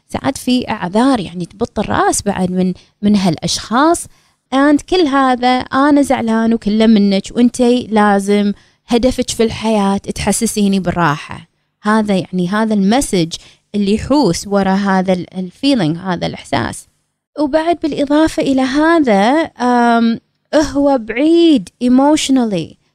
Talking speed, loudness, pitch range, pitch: 110 wpm, -14 LUFS, 195-270 Hz, 225 Hz